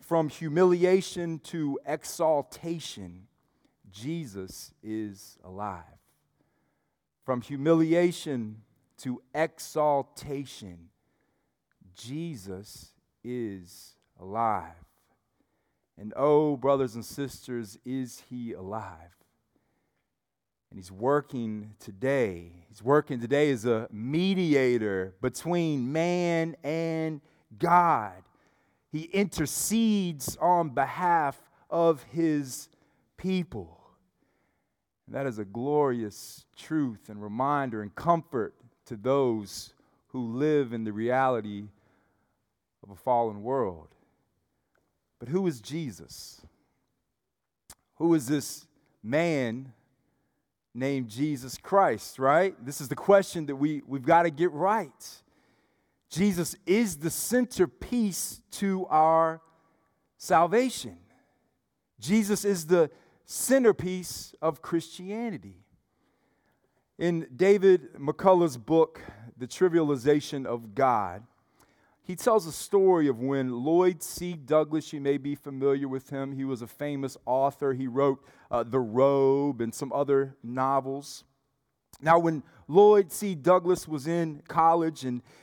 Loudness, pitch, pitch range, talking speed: -27 LUFS, 140 Hz, 120-165 Hz, 105 wpm